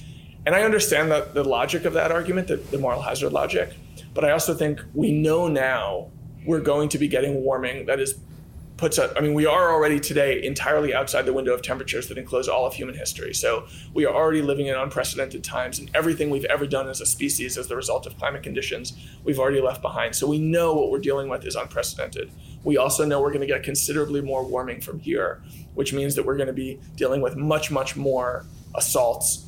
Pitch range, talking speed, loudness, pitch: 135-155 Hz, 220 wpm, -23 LUFS, 145 Hz